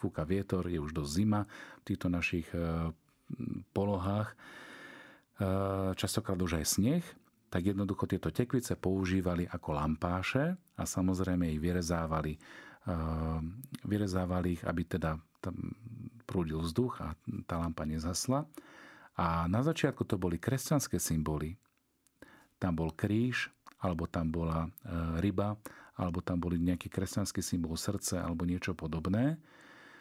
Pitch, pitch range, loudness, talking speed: 90 Hz, 85-105 Hz, -35 LUFS, 120 wpm